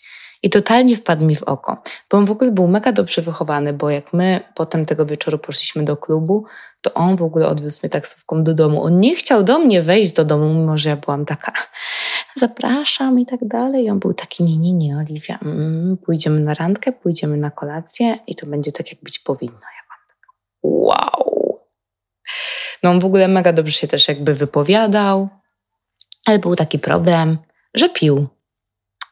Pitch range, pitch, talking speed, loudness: 155-210 Hz, 170 Hz, 190 wpm, -17 LUFS